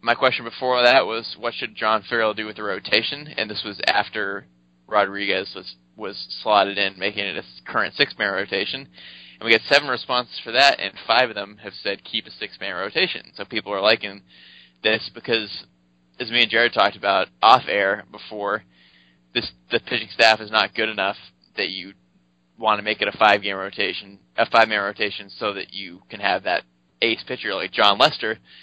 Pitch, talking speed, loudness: 100 Hz, 200 wpm, -21 LUFS